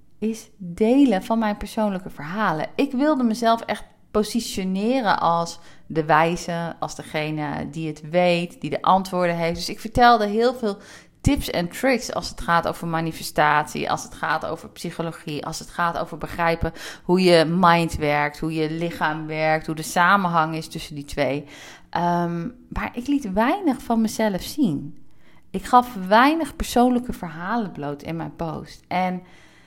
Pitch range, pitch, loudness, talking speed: 160-220 Hz, 175 Hz, -22 LUFS, 160 wpm